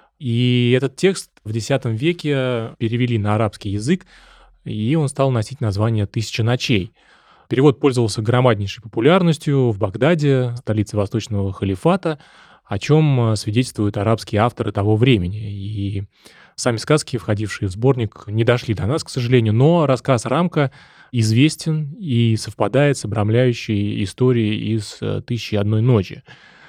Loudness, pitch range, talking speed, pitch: -19 LUFS, 110-135 Hz, 130 wpm, 120 Hz